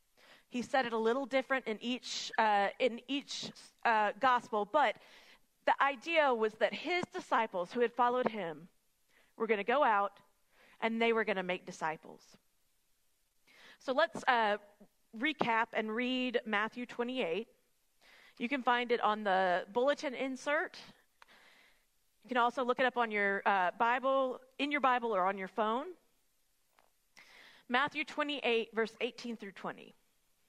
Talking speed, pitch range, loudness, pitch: 150 wpm, 215-260 Hz, -33 LUFS, 235 Hz